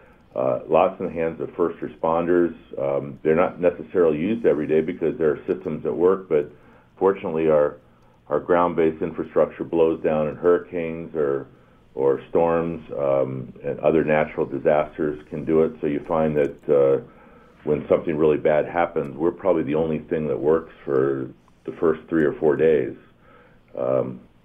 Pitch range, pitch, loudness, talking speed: 75-85 Hz, 80 Hz, -22 LUFS, 165 wpm